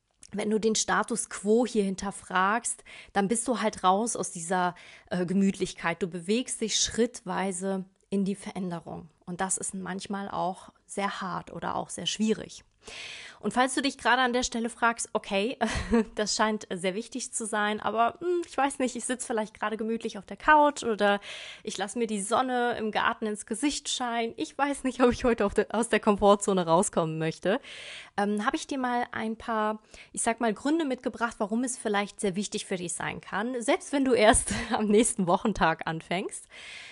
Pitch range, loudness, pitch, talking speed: 195-240 Hz, -28 LUFS, 215 Hz, 185 wpm